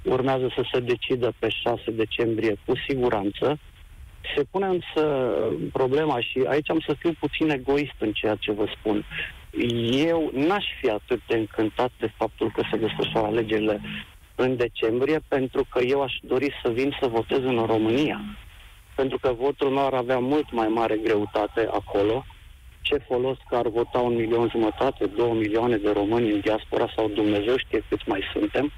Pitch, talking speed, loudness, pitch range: 120 Hz, 170 wpm, -25 LUFS, 105-135 Hz